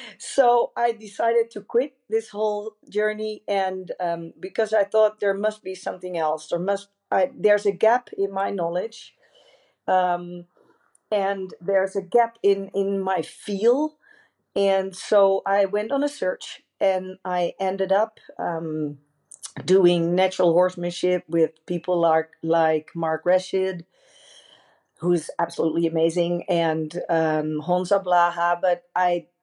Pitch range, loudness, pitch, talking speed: 175-210 Hz, -23 LUFS, 190 Hz, 135 wpm